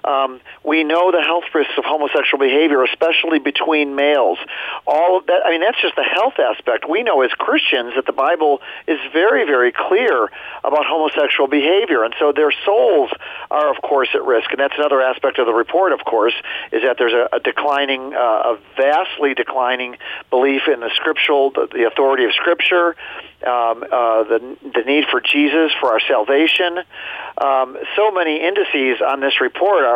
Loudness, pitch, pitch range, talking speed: -16 LUFS, 145 Hz, 135-165 Hz, 180 wpm